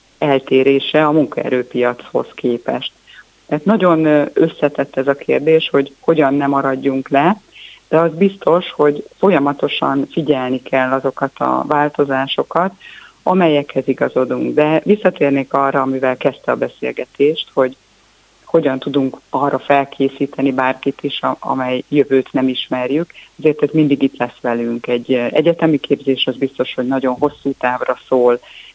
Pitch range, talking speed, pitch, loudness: 130-150 Hz, 125 wpm, 140 Hz, -16 LUFS